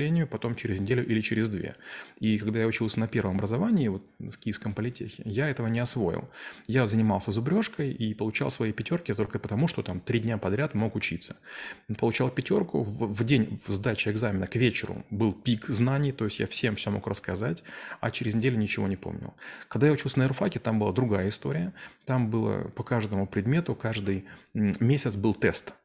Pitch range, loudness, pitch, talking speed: 105-125 Hz, -28 LUFS, 115 Hz, 185 wpm